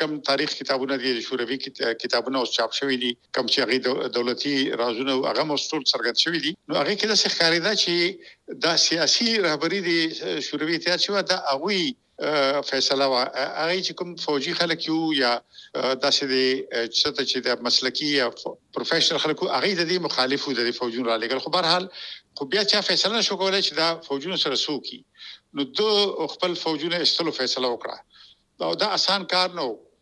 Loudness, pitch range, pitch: -23 LUFS, 130-180 Hz, 150 Hz